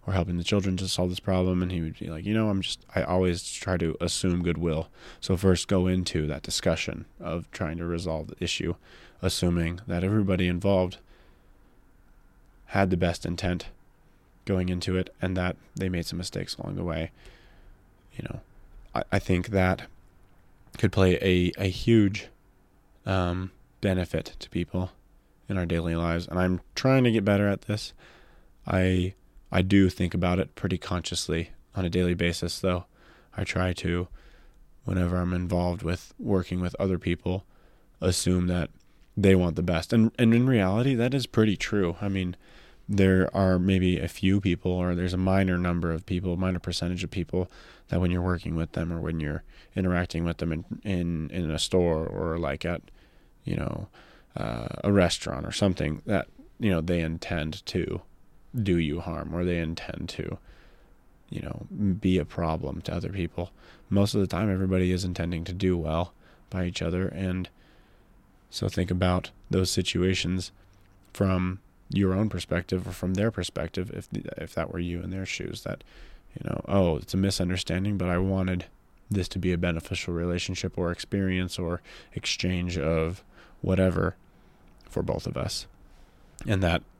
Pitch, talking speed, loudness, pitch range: 90 Hz, 175 wpm, -28 LUFS, 85-95 Hz